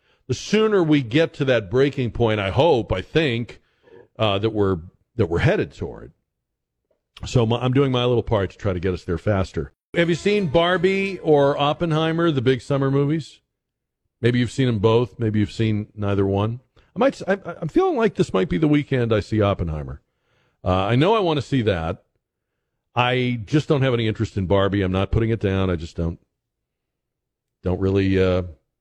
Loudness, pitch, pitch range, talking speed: -21 LUFS, 120 Hz, 100-150 Hz, 195 wpm